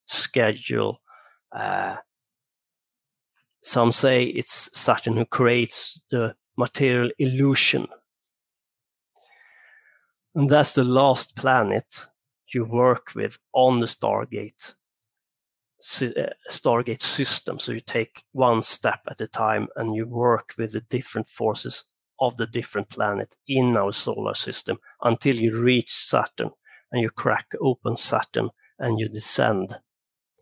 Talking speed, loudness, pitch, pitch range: 115 wpm, -22 LUFS, 120 Hz, 115-130 Hz